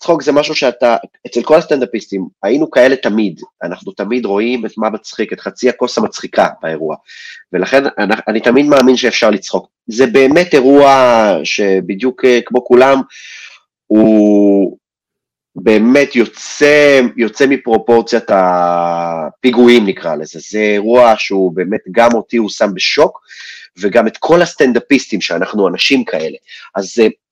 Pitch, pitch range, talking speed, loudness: 115 Hz, 100-135 Hz, 130 wpm, -11 LUFS